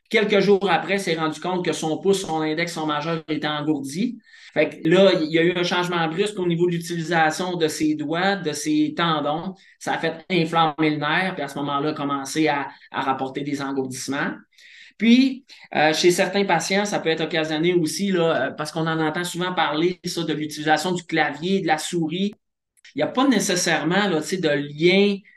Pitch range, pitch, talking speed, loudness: 155-180 Hz, 165 Hz, 205 wpm, -22 LUFS